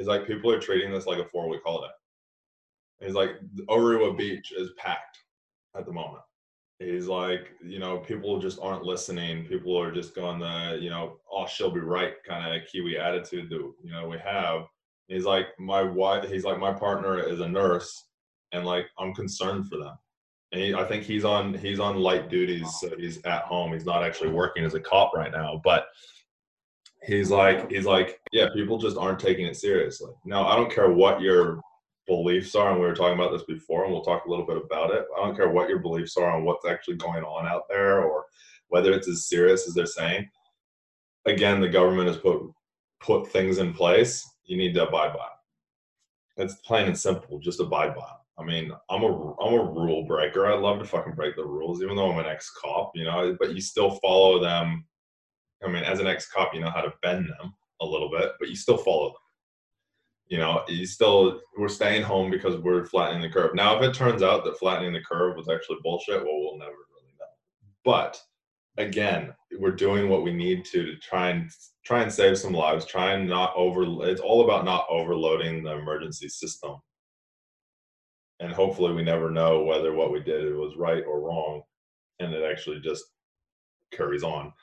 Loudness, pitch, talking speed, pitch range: -26 LUFS, 95 Hz, 205 wpm, 85-110 Hz